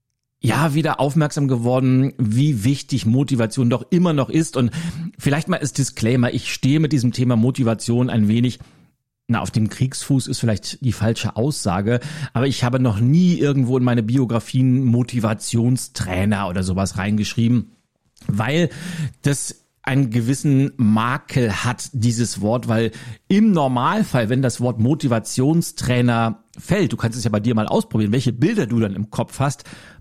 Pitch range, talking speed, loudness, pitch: 115-140 Hz, 155 wpm, -19 LUFS, 125 Hz